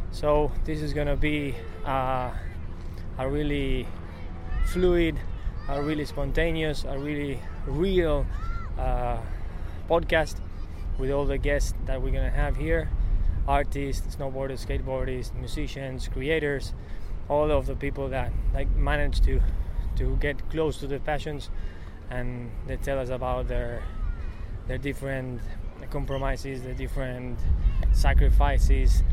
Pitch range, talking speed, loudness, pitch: 85-140 Hz, 115 wpm, -29 LUFS, 125 Hz